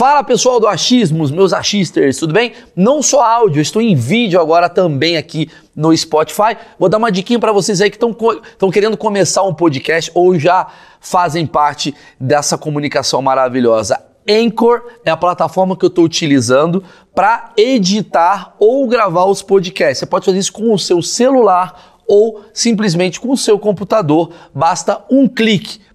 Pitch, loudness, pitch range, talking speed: 190 Hz, -13 LUFS, 165-220 Hz, 160 wpm